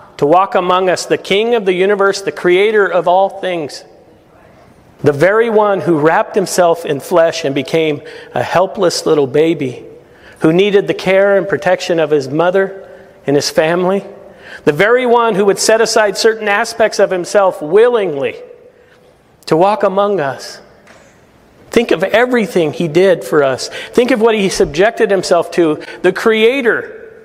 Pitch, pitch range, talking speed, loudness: 195 Hz, 175-220 Hz, 160 wpm, -13 LUFS